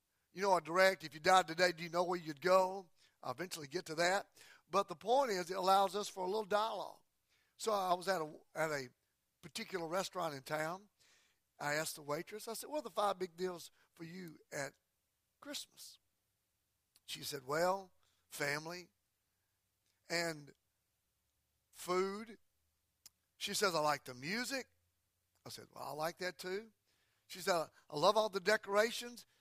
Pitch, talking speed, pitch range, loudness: 180 Hz, 170 wpm, 155-195 Hz, -38 LUFS